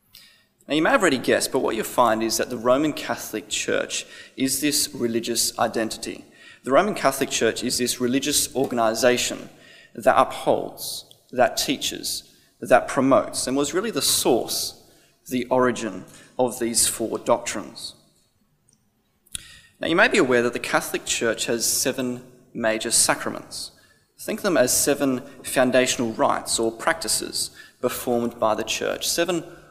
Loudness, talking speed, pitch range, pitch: -22 LUFS, 145 wpm, 115-130 Hz, 125 Hz